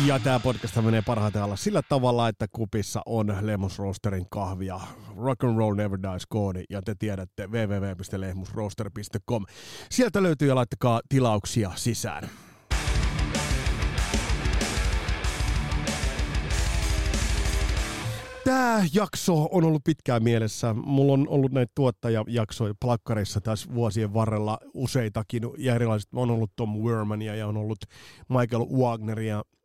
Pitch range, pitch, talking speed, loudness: 100-125 Hz, 110 Hz, 115 wpm, -27 LUFS